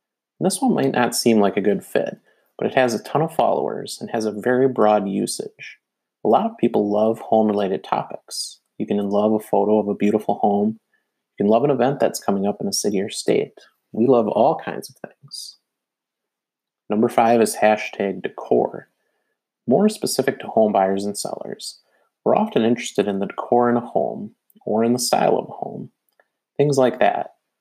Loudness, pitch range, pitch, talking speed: -20 LUFS, 105-120 Hz, 110 Hz, 195 wpm